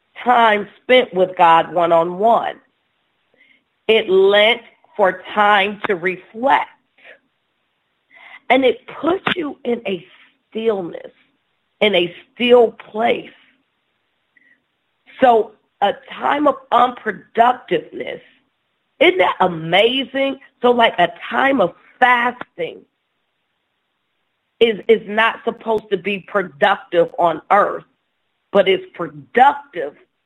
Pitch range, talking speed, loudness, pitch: 190-245 Hz, 95 wpm, -16 LUFS, 220 Hz